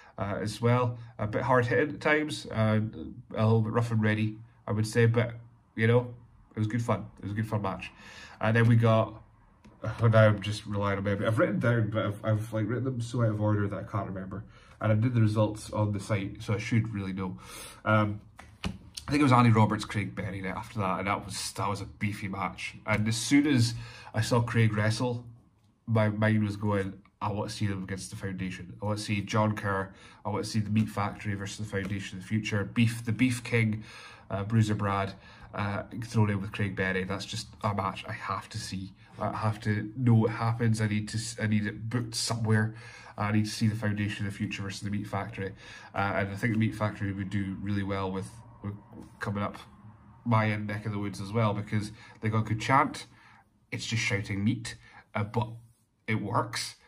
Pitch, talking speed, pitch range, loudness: 110 Hz, 230 wpm, 100-115 Hz, -30 LUFS